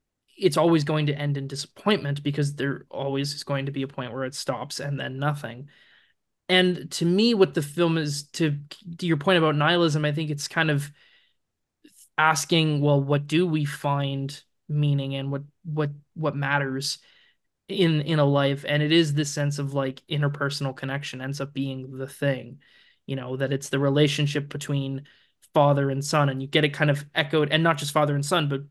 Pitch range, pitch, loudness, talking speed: 140-160 Hz, 145 Hz, -25 LUFS, 195 wpm